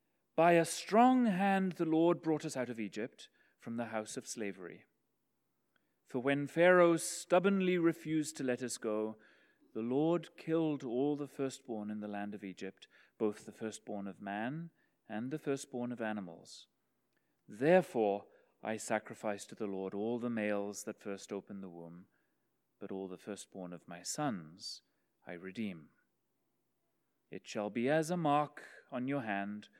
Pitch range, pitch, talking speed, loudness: 105-155 Hz, 120 Hz, 155 wpm, -35 LUFS